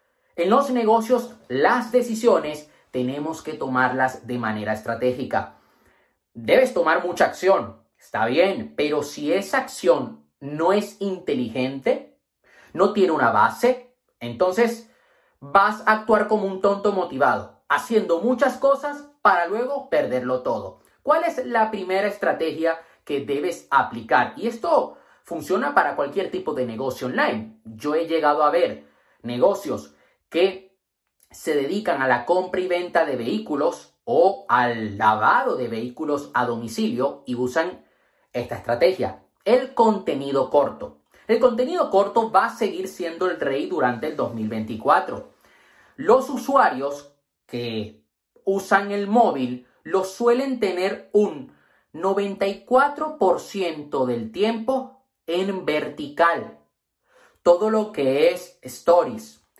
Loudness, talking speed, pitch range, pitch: -22 LUFS, 125 wpm, 140-230 Hz, 190 Hz